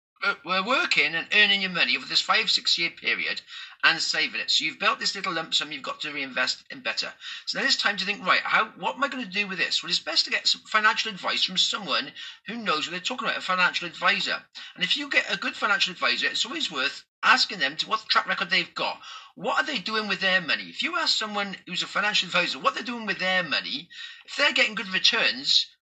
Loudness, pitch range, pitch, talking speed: -24 LUFS, 185-270 Hz, 215 Hz, 245 wpm